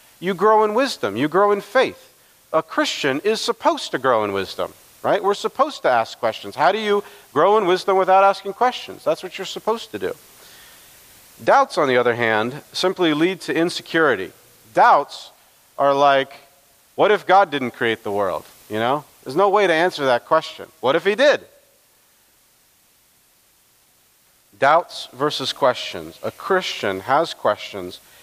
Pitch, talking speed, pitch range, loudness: 185 Hz, 160 wpm, 140-210 Hz, -19 LUFS